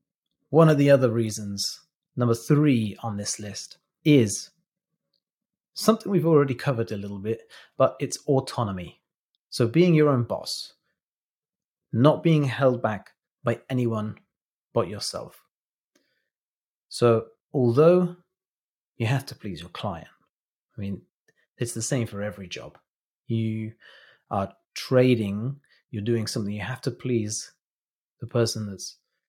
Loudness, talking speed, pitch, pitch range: -24 LUFS, 130 wpm, 120 Hz, 110-145 Hz